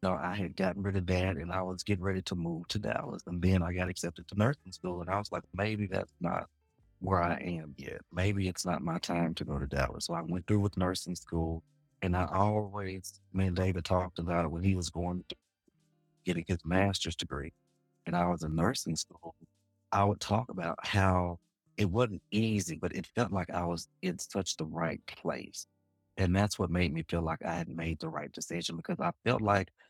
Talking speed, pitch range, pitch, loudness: 225 wpm, 85-100 Hz, 95 Hz, -33 LUFS